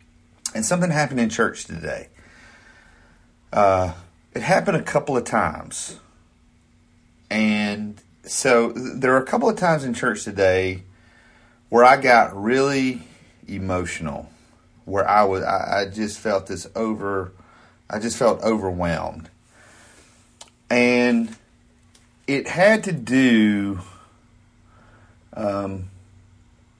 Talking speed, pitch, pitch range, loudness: 110 wpm, 105 Hz, 95-120 Hz, -21 LUFS